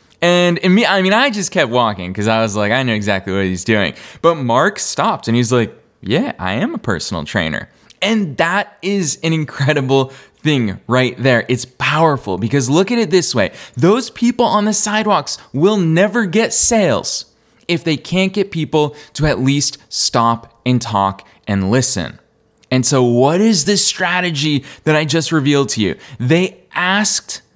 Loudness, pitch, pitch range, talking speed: -15 LUFS, 150 Hz, 120-185 Hz, 180 wpm